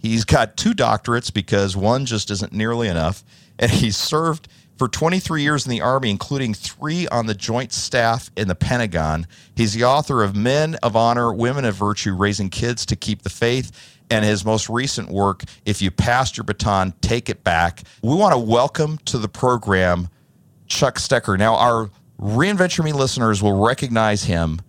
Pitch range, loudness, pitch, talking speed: 100-125 Hz, -19 LUFS, 115 Hz, 180 wpm